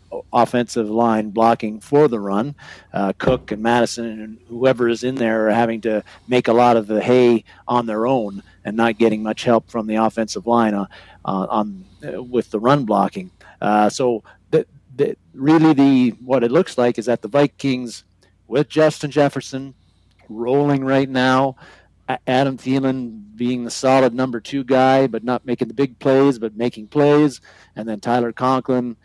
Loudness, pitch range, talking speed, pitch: -18 LUFS, 110-130 Hz, 175 wpm, 120 Hz